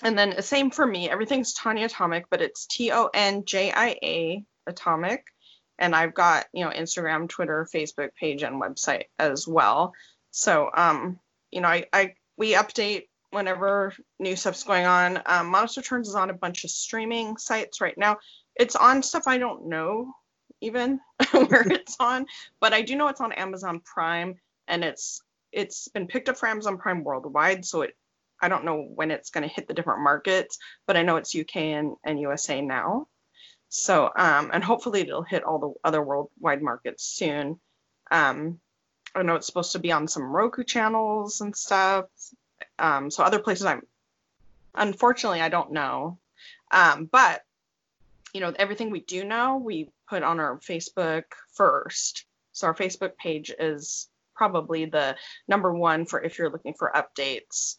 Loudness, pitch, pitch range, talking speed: -25 LUFS, 190 Hz, 165-225 Hz, 175 wpm